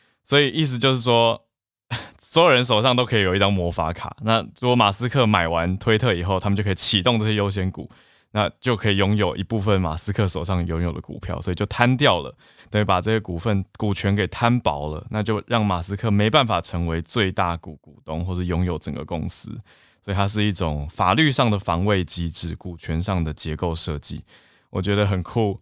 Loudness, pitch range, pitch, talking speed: -21 LUFS, 85-110 Hz, 100 Hz, 310 characters per minute